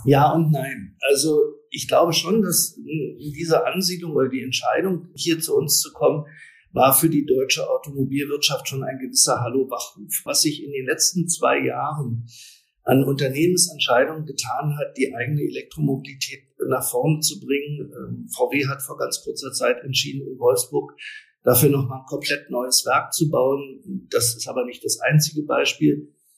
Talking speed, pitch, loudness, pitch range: 160 wpm, 145 Hz, -21 LUFS, 135-170 Hz